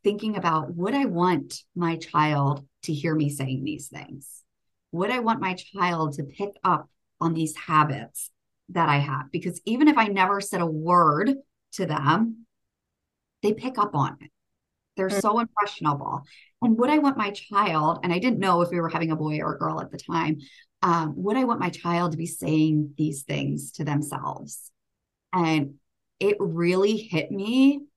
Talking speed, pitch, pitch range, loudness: 180 wpm, 170 Hz, 150-200 Hz, -25 LUFS